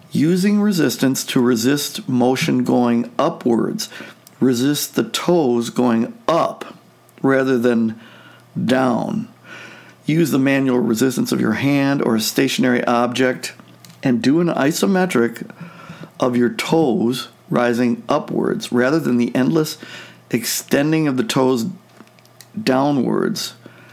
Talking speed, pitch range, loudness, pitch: 110 wpm, 120-160 Hz, -18 LUFS, 130 Hz